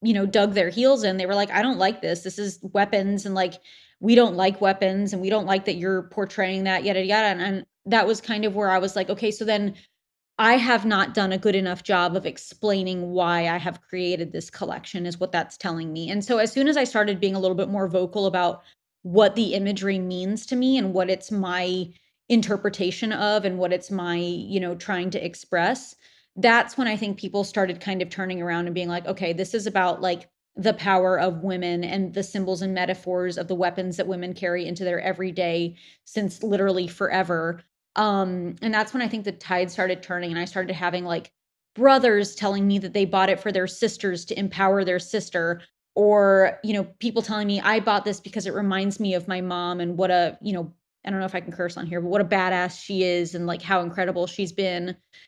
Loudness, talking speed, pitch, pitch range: -24 LUFS, 230 wpm, 190 Hz, 180-205 Hz